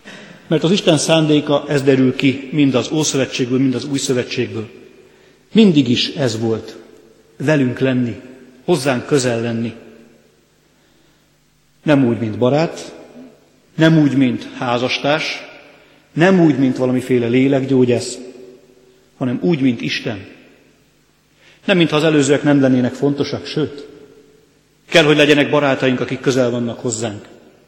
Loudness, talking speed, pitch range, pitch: -16 LUFS, 120 wpm, 125-145 Hz, 135 Hz